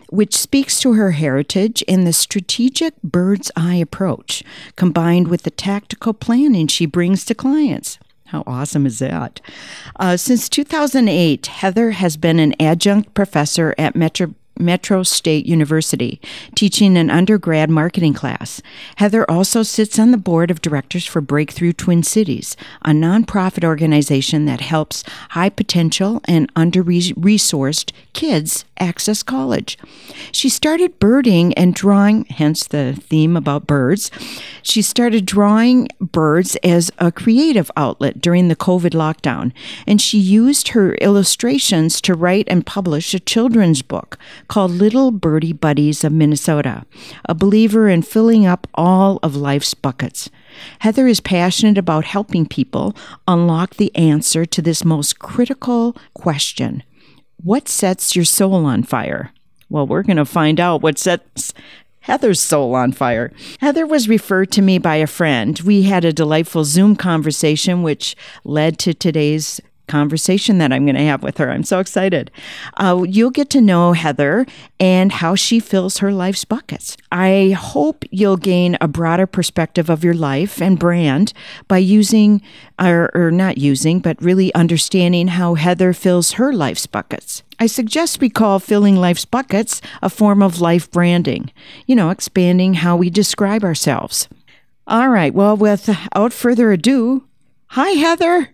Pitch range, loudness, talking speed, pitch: 160-210 Hz, -15 LUFS, 150 wpm, 180 Hz